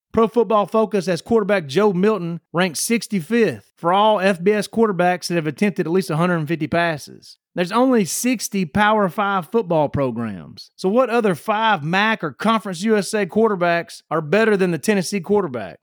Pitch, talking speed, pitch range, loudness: 200 Hz, 160 wpm, 170-215 Hz, -19 LUFS